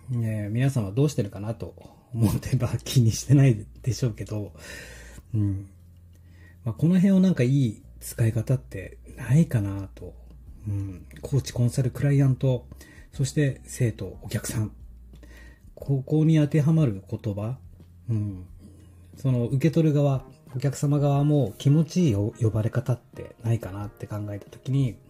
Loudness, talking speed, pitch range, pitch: -25 LUFS, 295 characters per minute, 100-135 Hz, 115 Hz